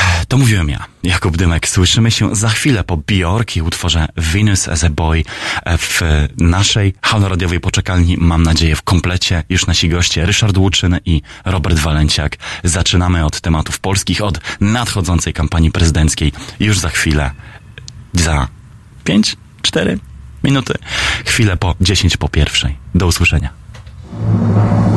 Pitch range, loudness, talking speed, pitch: 80-105 Hz, -14 LUFS, 125 wpm, 90 Hz